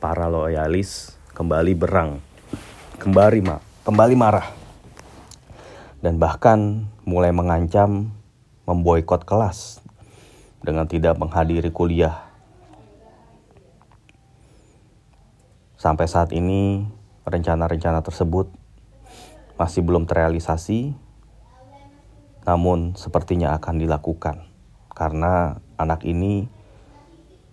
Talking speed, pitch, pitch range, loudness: 70 wpm, 90 Hz, 85-105 Hz, -21 LUFS